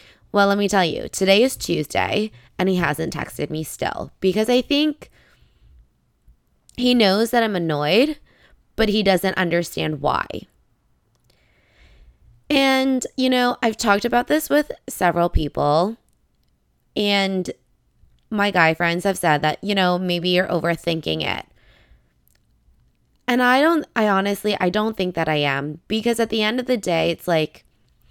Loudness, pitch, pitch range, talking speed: -20 LUFS, 185 Hz, 150-225 Hz, 150 wpm